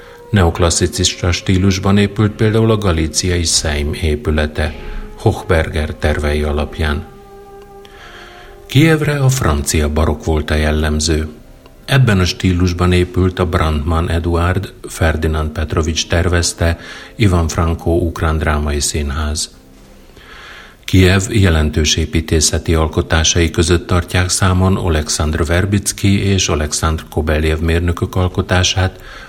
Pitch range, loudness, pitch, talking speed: 80-95 Hz, -15 LUFS, 85 Hz, 95 wpm